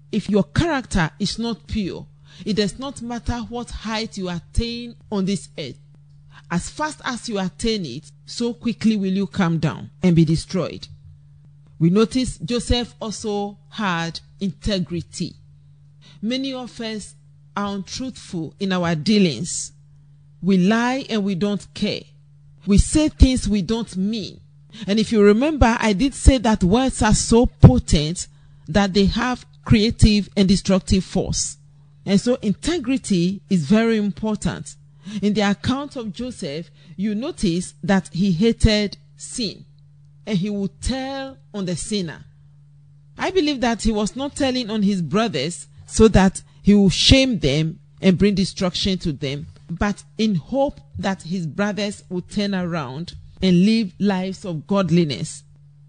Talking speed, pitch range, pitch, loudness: 145 wpm, 155-220 Hz, 195 Hz, -21 LUFS